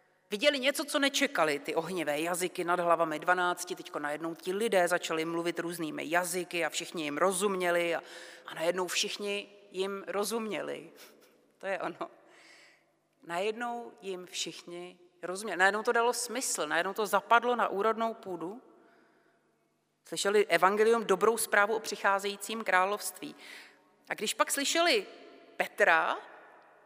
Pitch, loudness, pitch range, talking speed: 190 Hz, -30 LUFS, 175-220 Hz, 125 wpm